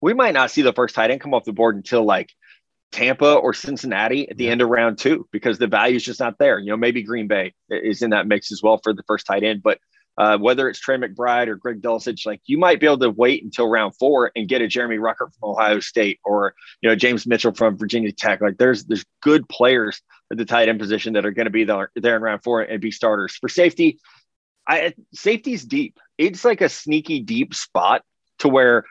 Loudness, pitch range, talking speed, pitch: -19 LUFS, 110-135 Hz, 245 wpm, 115 Hz